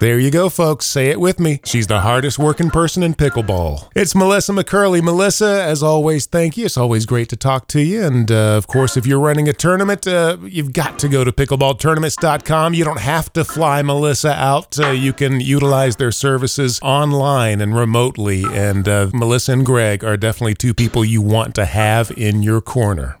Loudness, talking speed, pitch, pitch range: -15 LUFS, 200 wpm, 135 Hz, 115-155 Hz